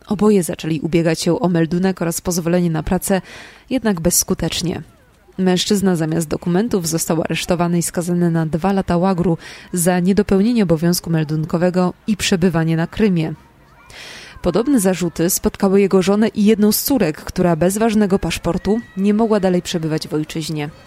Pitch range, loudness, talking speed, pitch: 165-200 Hz, -17 LUFS, 145 wpm, 180 Hz